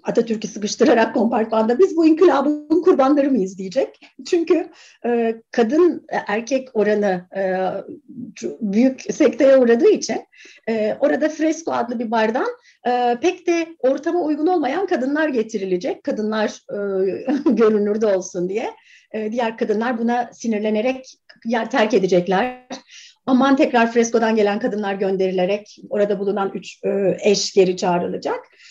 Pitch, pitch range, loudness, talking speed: 235 Hz, 210-295 Hz, -19 LUFS, 125 wpm